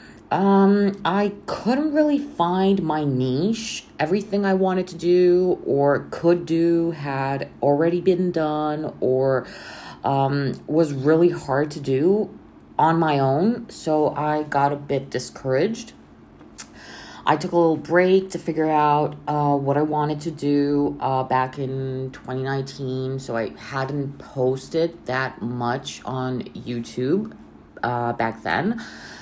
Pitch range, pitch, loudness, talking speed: 135-175 Hz, 150 Hz, -22 LUFS, 130 wpm